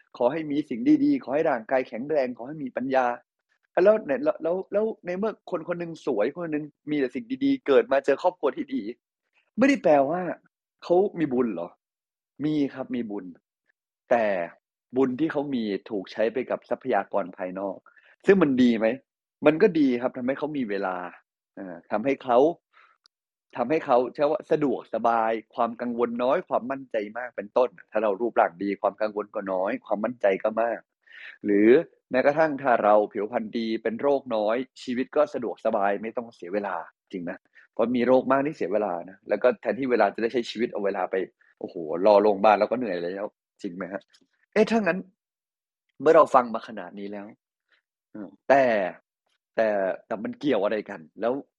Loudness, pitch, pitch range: -25 LUFS, 130 Hz, 110-165 Hz